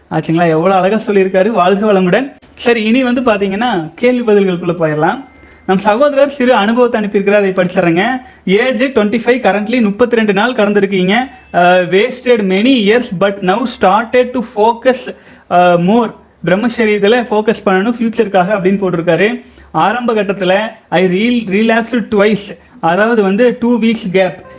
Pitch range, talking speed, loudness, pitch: 190-240 Hz, 130 wpm, -12 LUFS, 210 Hz